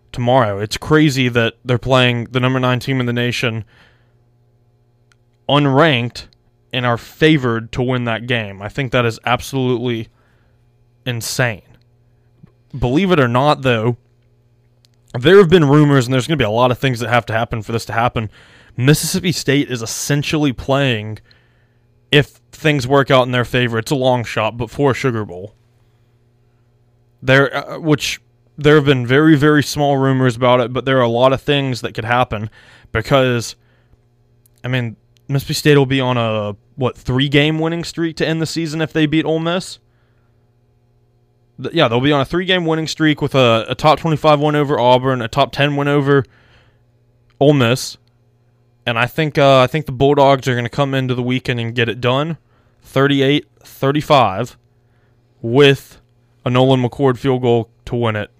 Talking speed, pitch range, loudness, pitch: 175 wpm, 120-140 Hz, -15 LUFS, 125 Hz